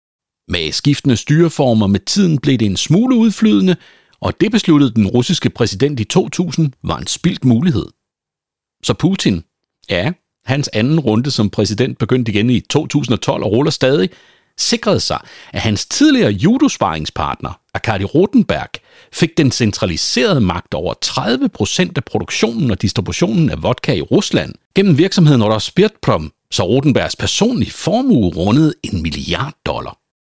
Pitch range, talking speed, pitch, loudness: 110-175 Hz, 140 wpm, 140 Hz, -15 LUFS